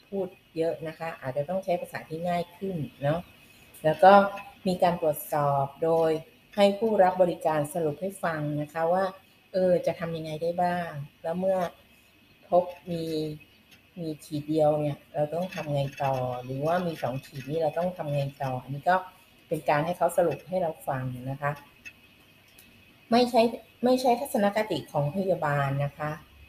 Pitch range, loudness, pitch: 145-180 Hz, -28 LUFS, 165 Hz